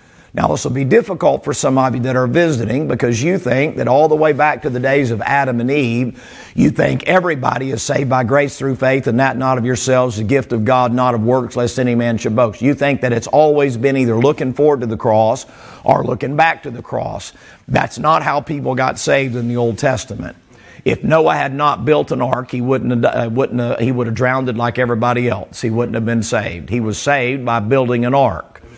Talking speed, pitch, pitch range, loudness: 235 wpm, 125 Hz, 120-140 Hz, -15 LUFS